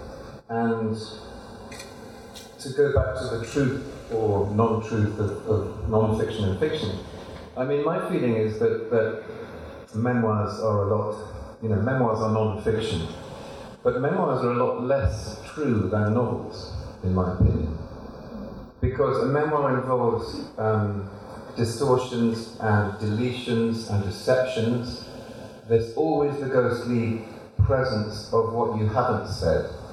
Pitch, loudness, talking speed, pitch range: 110 Hz, -25 LUFS, 130 wpm, 105-120 Hz